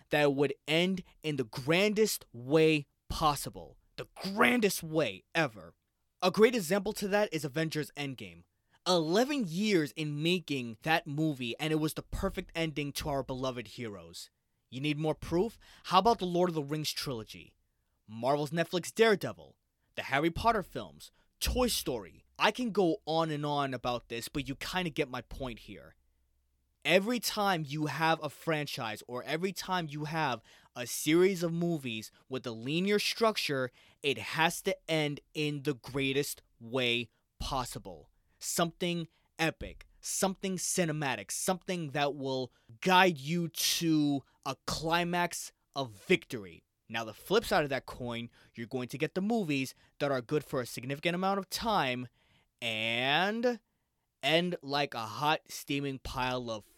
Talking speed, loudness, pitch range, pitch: 155 wpm, -32 LUFS, 125-175 Hz, 150 Hz